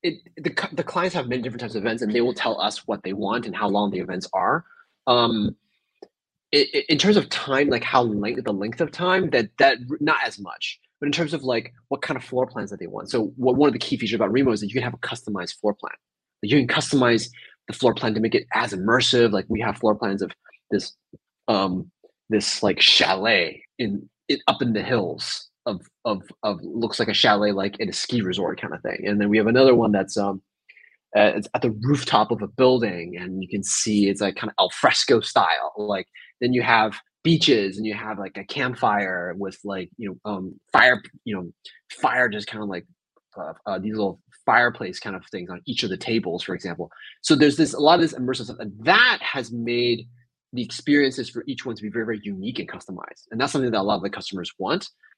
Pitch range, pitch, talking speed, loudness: 105-130 Hz, 115 Hz, 240 wpm, -22 LUFS